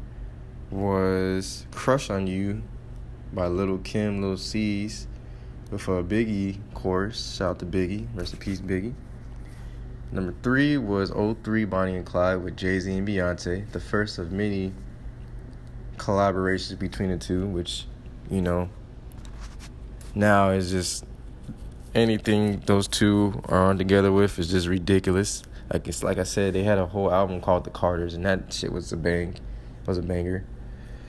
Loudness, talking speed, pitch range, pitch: -26 LUFS, 155 wpm, 90-100 Hz, 95 Hz